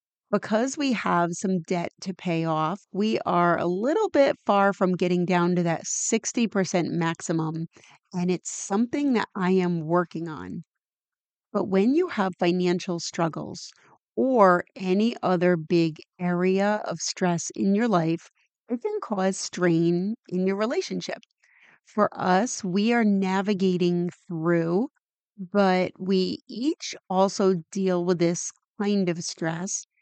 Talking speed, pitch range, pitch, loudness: 135 wpm, 175-205 Hz, 185 Hz, -25 LUFS